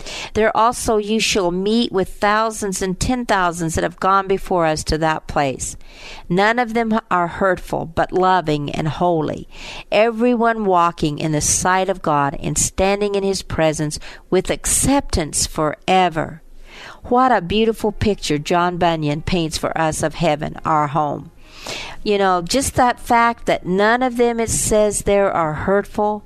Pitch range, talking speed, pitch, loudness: 165-220 Hz, 160 wpm, 190 Hz, -18 LUFS